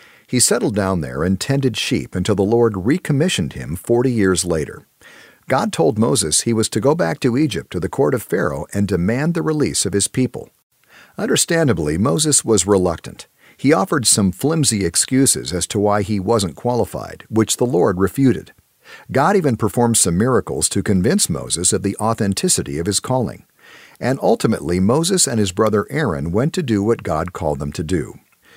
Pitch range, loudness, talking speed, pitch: 95-125 Hz, -17 LUFS, 180 wpm, 105 Hz